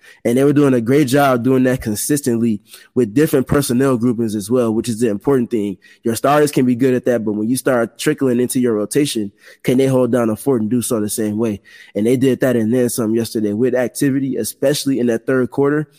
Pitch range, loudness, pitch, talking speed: 115-135 Hz, -17 LUFS, 125 Hz, 235 wpm